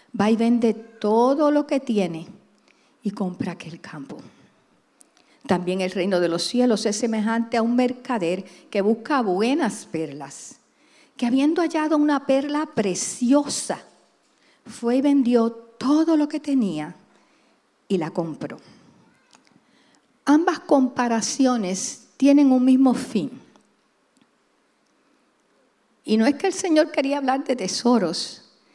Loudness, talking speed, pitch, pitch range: -22 LUFS, 120 wpm, 240 Hz, 200-280 Hz